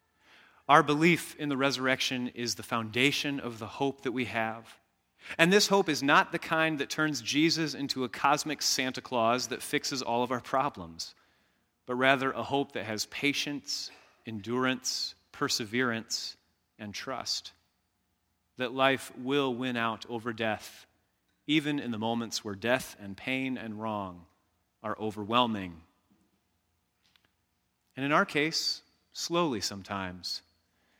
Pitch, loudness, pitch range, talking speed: 125 Hz, -30 LUFS, 110-140 Hz, 135 wpm